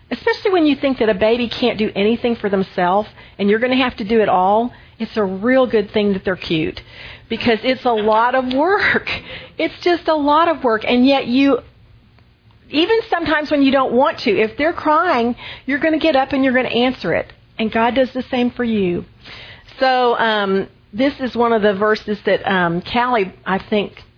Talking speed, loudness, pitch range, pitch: 210 wpm, -17 LUFS, 215-275 Hz, 240 Hz